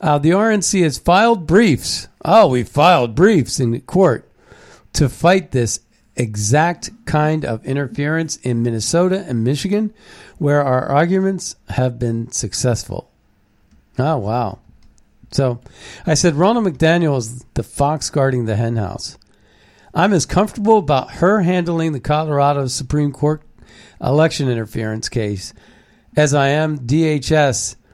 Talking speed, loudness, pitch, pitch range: 130 wpm, -17 LUFS, 145 Hz, 120-165 Hz